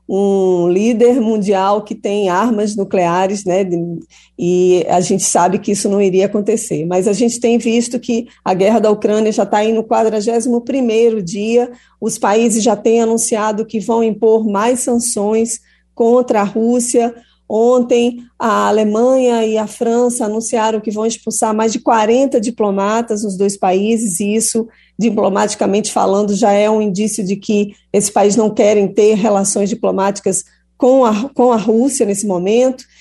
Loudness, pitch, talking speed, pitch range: -14 LUFS, 220 Hz, 160 wpm, 205-235 Hz